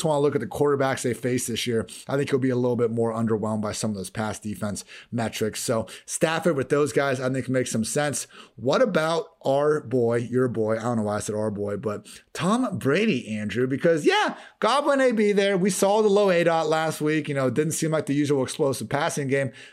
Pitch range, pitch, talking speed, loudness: 115-155 Hz, 135 Hz, 235 wpm, -24 LUFS